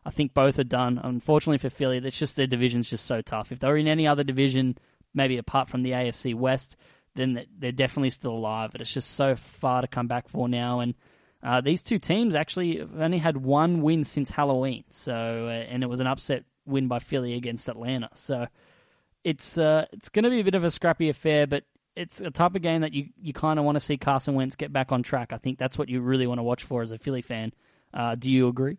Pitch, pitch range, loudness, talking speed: 135 Hz, 125-150 Hz, -26 LUFS, 245 wpm